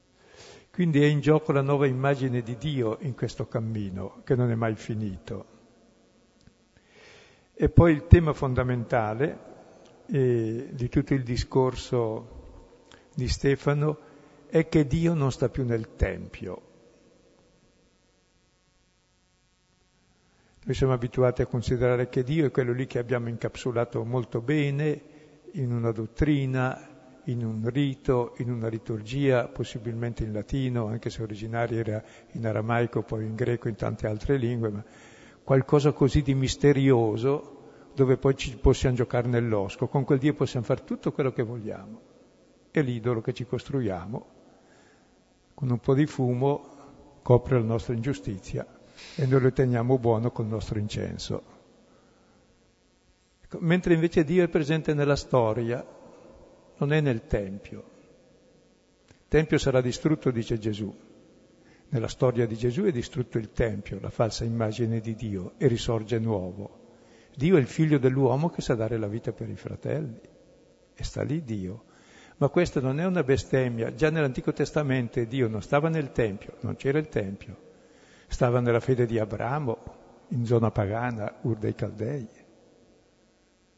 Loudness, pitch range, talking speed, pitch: -27 LUFS, 115-140 Hz, 145 wpm, 125 Hz